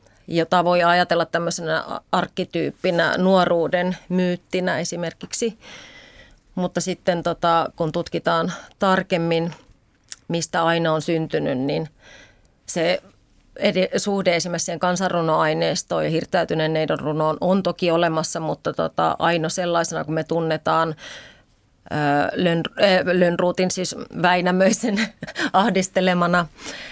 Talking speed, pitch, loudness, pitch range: 100 wpm, 175 Hz, -21 LUFS, 165-185 Hz